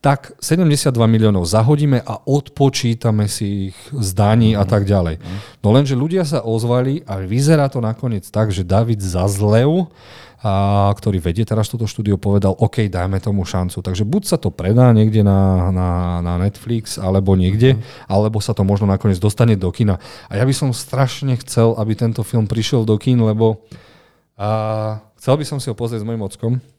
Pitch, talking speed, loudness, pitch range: 110 Hz, 175 wpm, -17 LUFS, 100-125 Hz